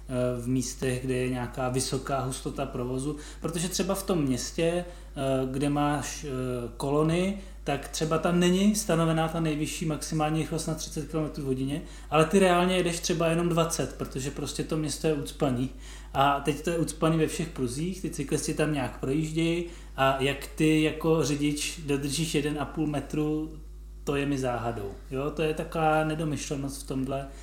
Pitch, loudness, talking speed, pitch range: 150 Hz, -28 LUFS, 165 wpm, 135-160 Hz